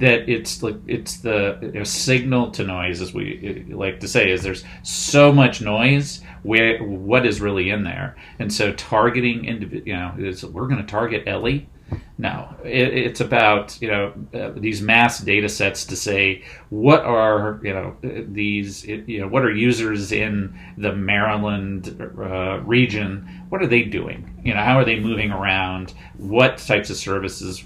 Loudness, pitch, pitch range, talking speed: -20 LUFS, 105 Hz, 95-120 Hz, 175 wpm